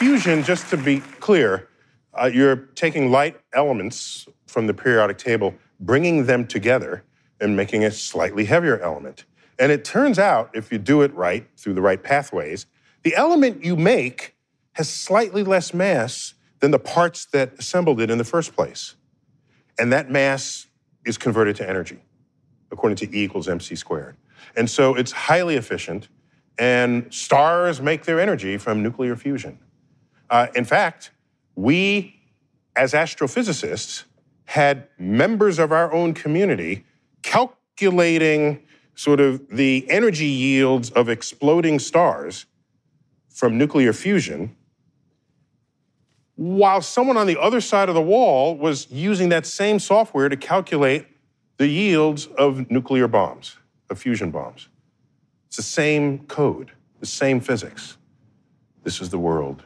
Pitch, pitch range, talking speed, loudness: 145 Hz, 130-170 Hz, 140 wpm, -20 LUFS